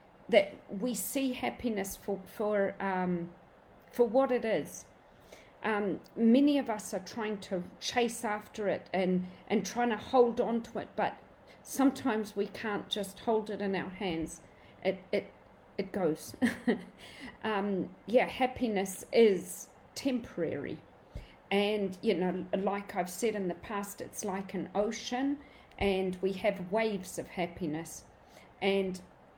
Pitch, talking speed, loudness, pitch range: 205 Hz, 140 wpm, -33 LUFS, 190-230 Hz